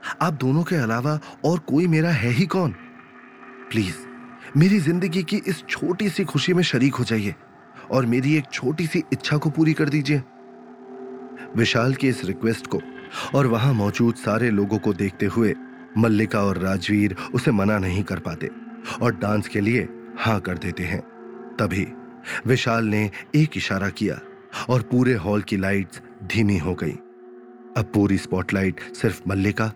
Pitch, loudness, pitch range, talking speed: 120 Hz, -22 LUFS, 105-140 Hz, 160 wpm